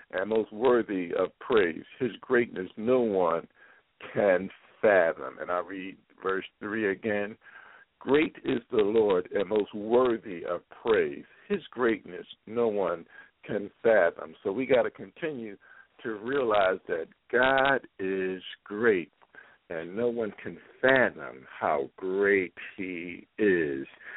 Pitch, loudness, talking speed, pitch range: 105 Hz, -28 LUFS, 130 wpm, 95-130 Hz